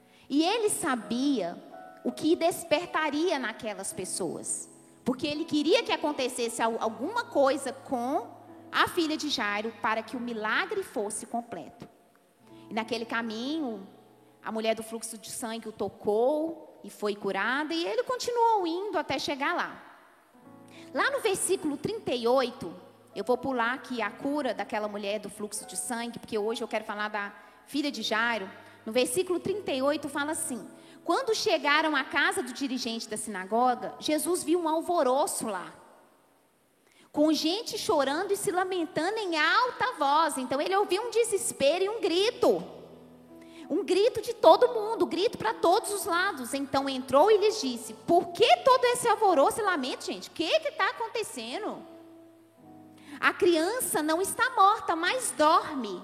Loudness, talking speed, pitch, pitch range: -28 LUFS, 150 wpm, 305 Hz, 235-370 Hz